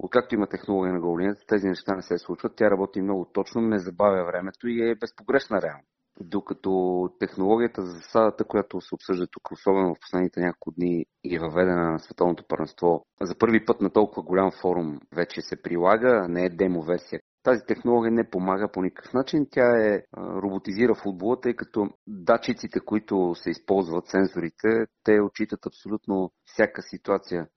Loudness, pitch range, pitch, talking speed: -25 LUFS, 90-110 Hz, 100 Hz, 170 wpm